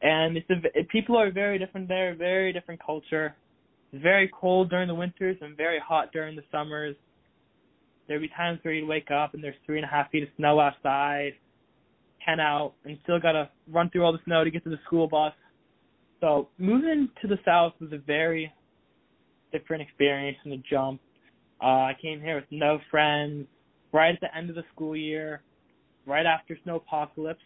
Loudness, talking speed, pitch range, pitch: -27 LUFS, 195 wpm, 150-170 Hz, 155 Hz